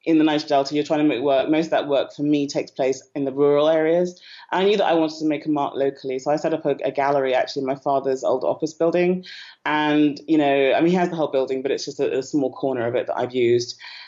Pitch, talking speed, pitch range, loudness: 145 Hz, 280 wpm, 135-160 Hz, -21 LUFS